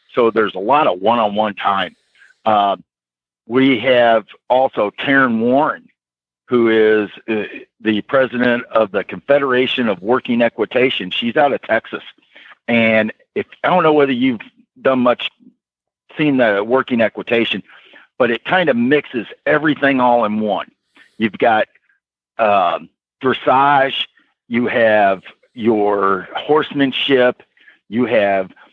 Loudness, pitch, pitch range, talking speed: -16 LUFS, 120 Hz, 105-135 Hz, 125 wpm